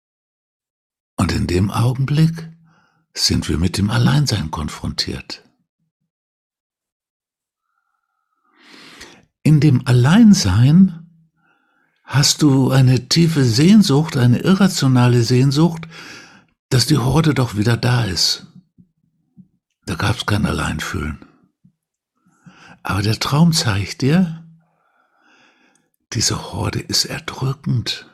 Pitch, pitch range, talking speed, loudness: 145 Hz, 120-170 Hz, 85 wpm, -16 LUFS